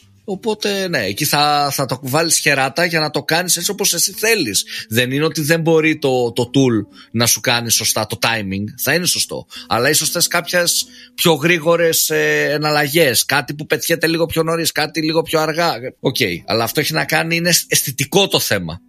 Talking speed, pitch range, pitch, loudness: 190 wpm, 130-170 Hz, 155 Hz, -16 LUFS